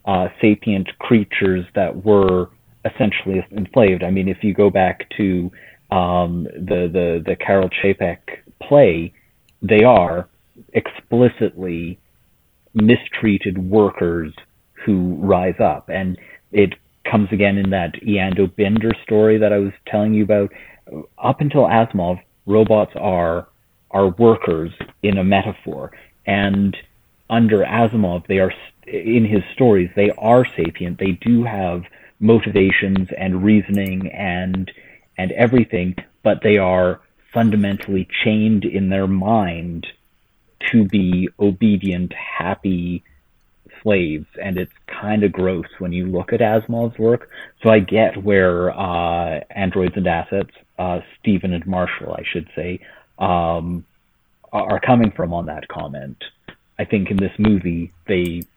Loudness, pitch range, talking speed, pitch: -18 LUFS, 90-105 Hz, 130 wpm, 95 Hz